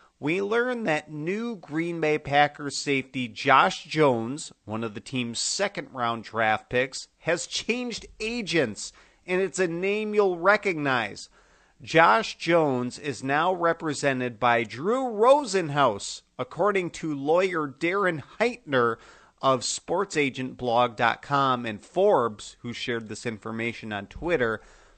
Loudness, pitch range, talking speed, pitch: -25 LUFS, 125-185 Hz, 120 wpm, 145 Hz